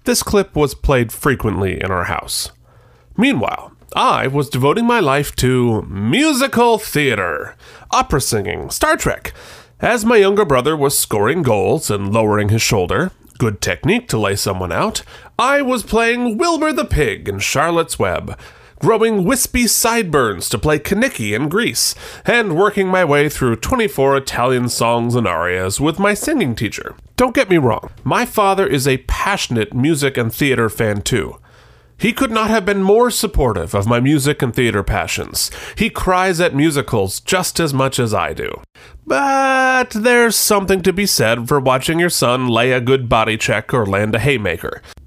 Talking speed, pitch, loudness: 165 wpm, 145 Hz, -16 LUFS